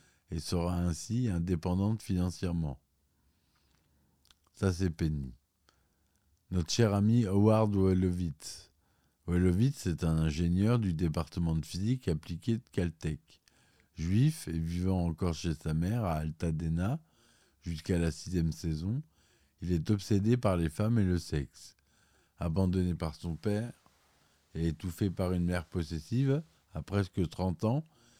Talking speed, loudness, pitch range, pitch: 130 wpm, -32 LUFS, 80-100 Hz, 90 Hz